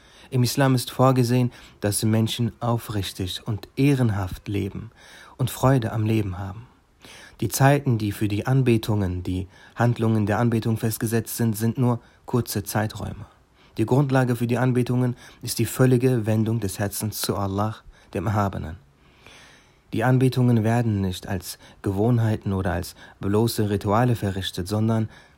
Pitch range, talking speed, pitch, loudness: 100-120 Hz, 135 wpm, 110 Hz, -23 LUFS